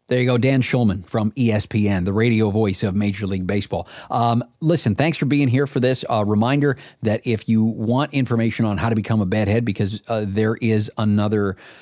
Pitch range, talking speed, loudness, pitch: 105-125 Hz, 205 wpm, -20 LUFS, 110 Hz